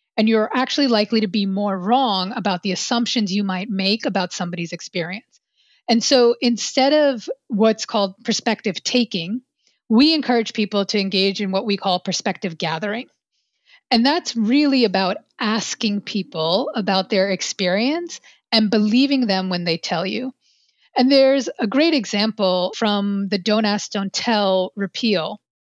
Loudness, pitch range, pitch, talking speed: -19 LUFS, 195-245 Hz, 215 Hz, 150 wpm